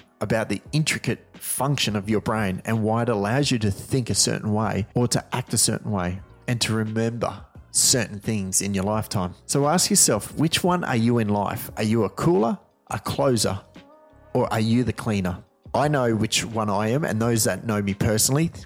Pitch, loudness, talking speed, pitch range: 115 Hz, -23 LUFS, 205 wpm, 105-125 Hz